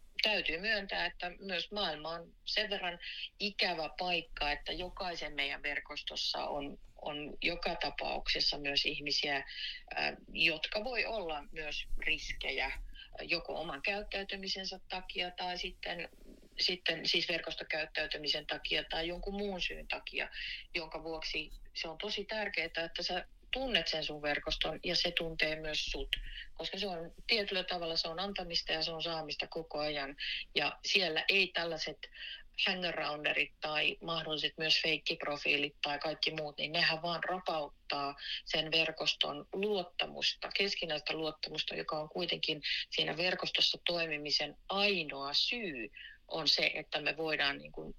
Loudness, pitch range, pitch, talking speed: -35 LUFS, 155-185 Hz, 165 Hz, 135 wpm